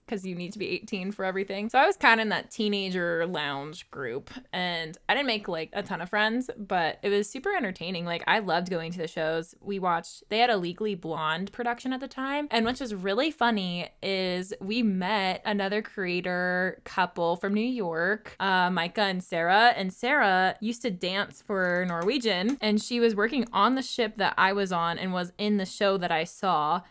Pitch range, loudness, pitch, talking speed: 180-220 Hz, -27 LUFS, 195 Hz, 210 wpm